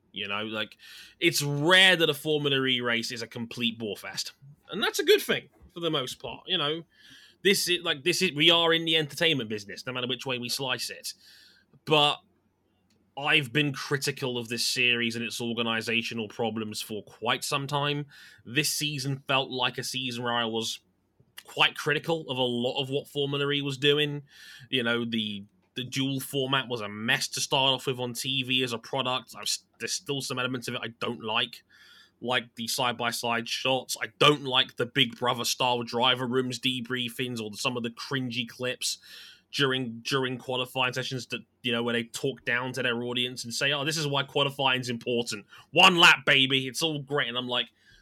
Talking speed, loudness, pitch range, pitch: 200 wpm, -26 LUFS, 120-145 Hz, 130 Hz